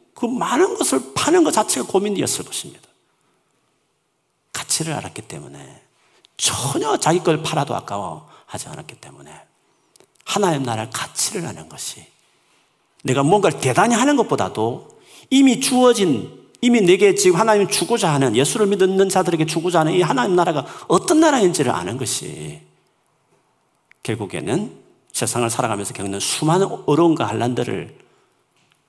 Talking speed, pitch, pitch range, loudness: 315 characters per minute, 175 Hz, 125-205 Hz, -18 LUFS